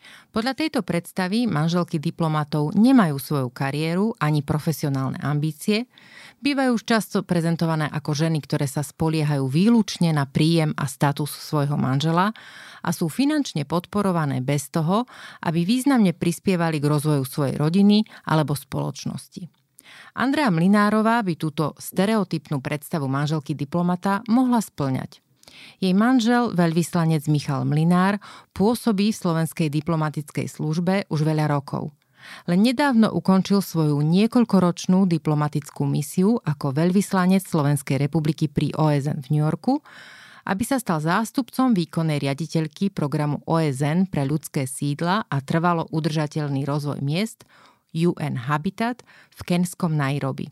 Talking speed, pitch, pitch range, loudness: 120 wpm, 165 Hz, 150-195 Hz, -22 LUFS